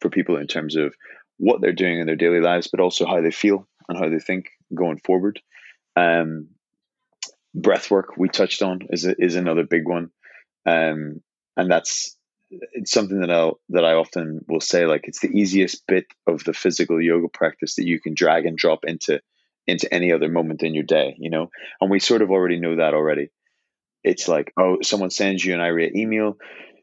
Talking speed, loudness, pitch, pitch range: 200 wpm, -21 LUFS, 85 Hz, 80-95 Hz